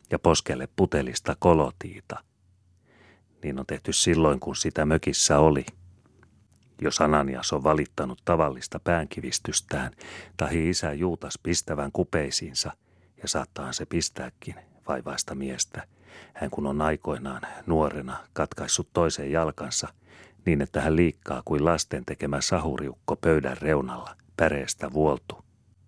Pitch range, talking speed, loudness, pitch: 75-90 Hz, 115 wpm, -26 LUFS, 80 Hz